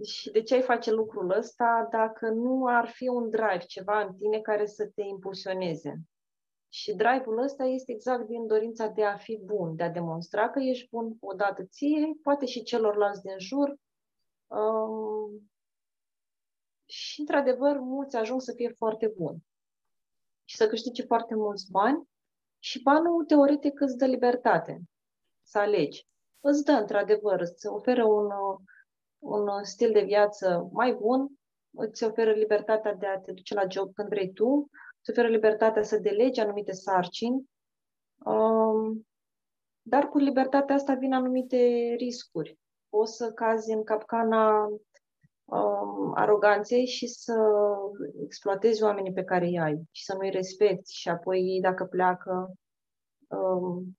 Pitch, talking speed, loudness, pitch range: 220 Hz, 145 wpm, -27 LUFS, 195-245 Hz